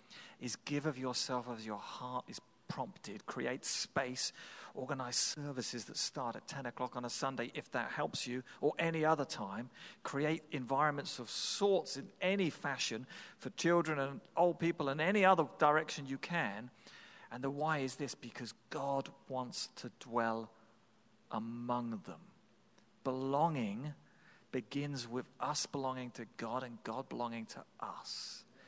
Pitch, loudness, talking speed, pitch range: 135 Hz, -38 LUFS, 150 wpm, 120-150 Hz